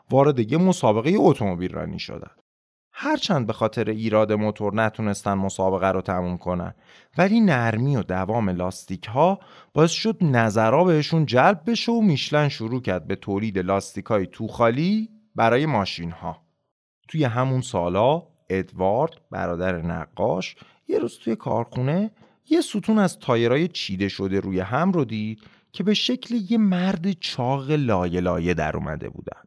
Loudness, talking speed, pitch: -23 LUFS, 145 wpm, 115 Hz